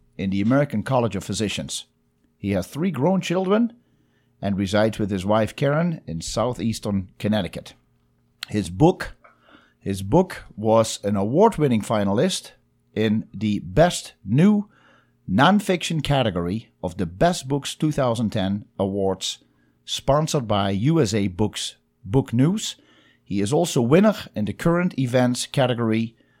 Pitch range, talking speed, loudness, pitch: 100-150 Hz, 125 wpm, -22 LUFS, 110 Hz